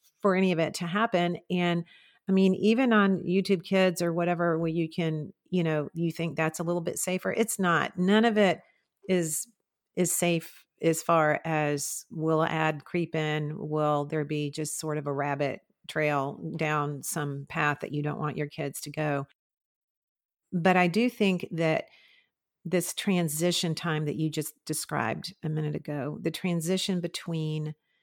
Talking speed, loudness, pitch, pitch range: 170 wpm, -28 LUFS, 165 Hz, 150-180 Hz